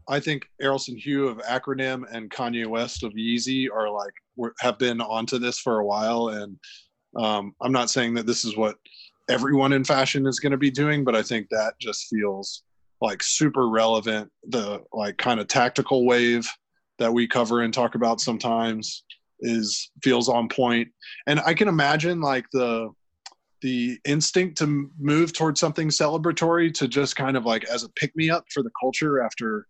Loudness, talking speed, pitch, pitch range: -24 LUFS, 180 wpm, 125 Hz, 115-140 Hz